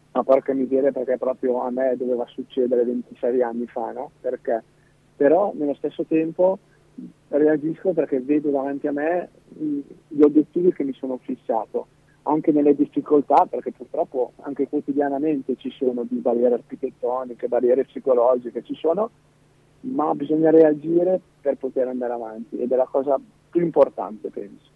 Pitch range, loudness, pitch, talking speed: 125-155 Hz, -22 LUFS, 140 Hz, 145 wpm